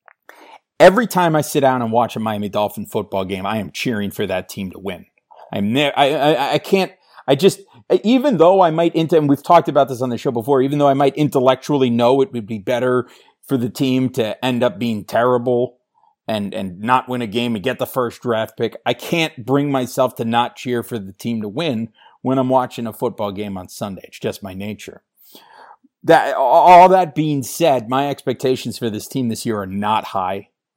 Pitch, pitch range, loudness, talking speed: 130 Hz, 115-150 Hz, -17 LUFS, 215 wpm